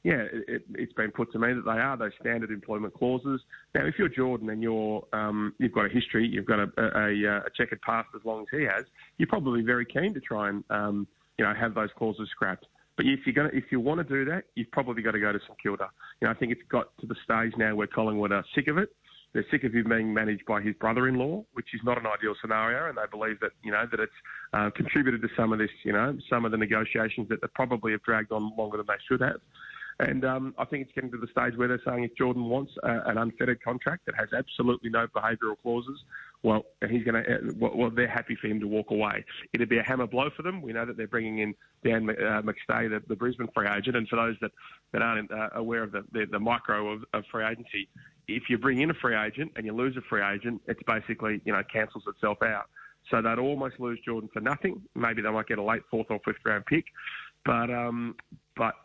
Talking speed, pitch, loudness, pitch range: 250 wpm, 115 Hz, -29 LUFS, 110-125 Hz